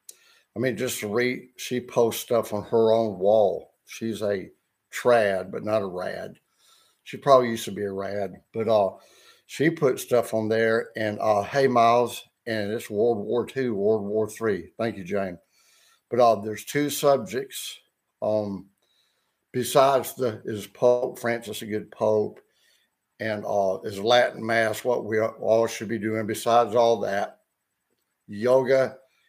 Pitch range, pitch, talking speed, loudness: 105-120 Hz, 115 Hz, 160 wpm, -25 LUFS